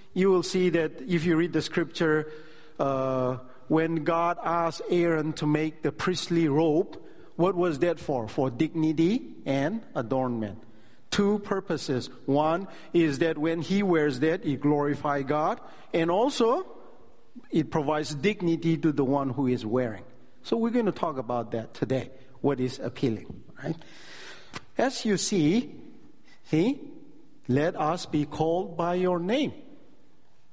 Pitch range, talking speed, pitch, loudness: 140-180 Hz, 145 wpm, 160 Hz, -27 LUFS